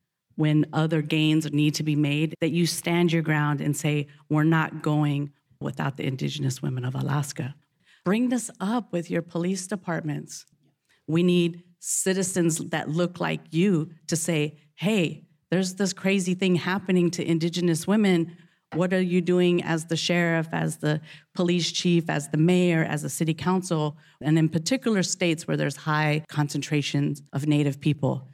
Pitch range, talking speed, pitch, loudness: 150-175 Hz, 165 wpm, 160 Hz, -25 LUFS